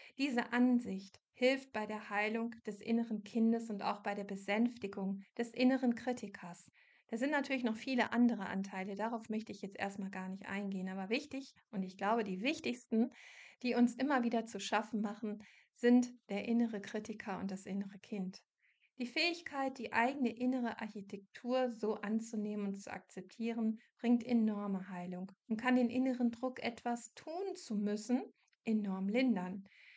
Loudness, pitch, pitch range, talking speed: -37 LUFS, 225 Hz, 200-245 Hz, 160 wpm